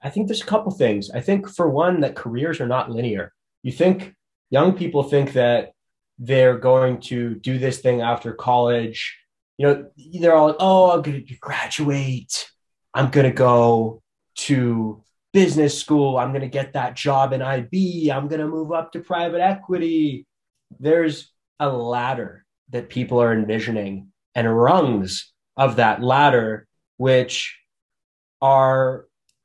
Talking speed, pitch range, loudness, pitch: 145 wpm, 120-160 Hz, -20 LUFS, 135 Hz